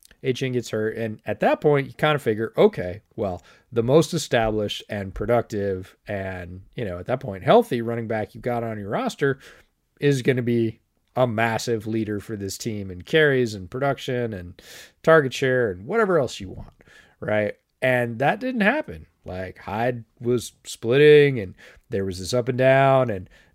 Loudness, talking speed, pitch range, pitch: -23 LUFS, 180 wpm, 105-130 Hz, 115 Hz